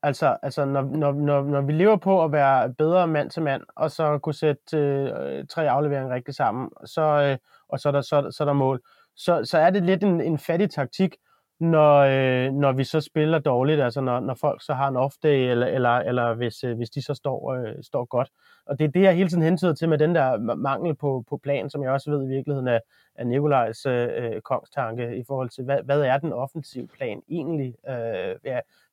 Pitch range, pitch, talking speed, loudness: 135-155 Hz, 145 Hz, 235 wpm, -23 LUFS